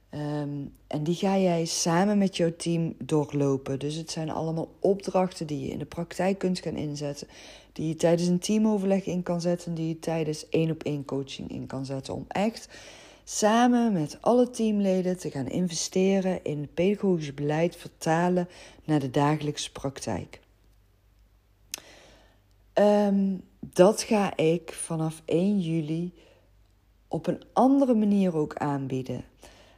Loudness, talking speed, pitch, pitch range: -27 LUFS, 145 wpm, 165 Hz, 145-190 Hz